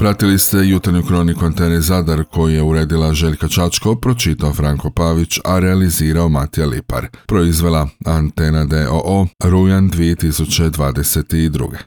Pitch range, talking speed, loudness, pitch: 80-90 Hz, 115 wpm, -15 LUFS, 85 Hz